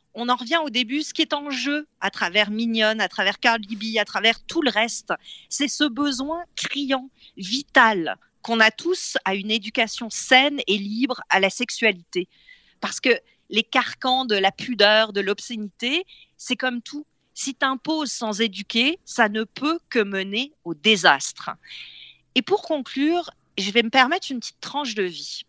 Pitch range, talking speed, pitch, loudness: 215-285 Hz, 170 wpm, 240 Hz, -22 LUFS